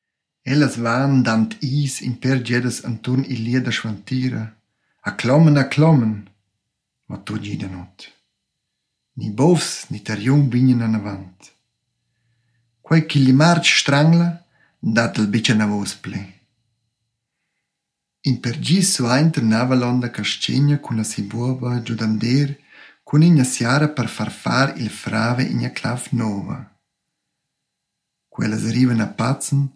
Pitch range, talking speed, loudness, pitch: 110-140 Hz, 125 wpm, -19 LUFS, 125 Hz